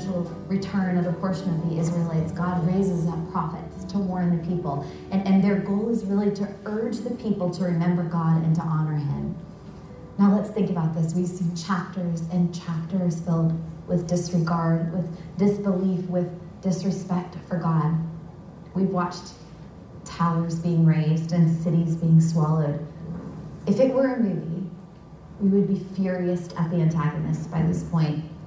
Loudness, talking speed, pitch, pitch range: -25 LUFS, 160 wpm, 175 Hz, 165-185 Hz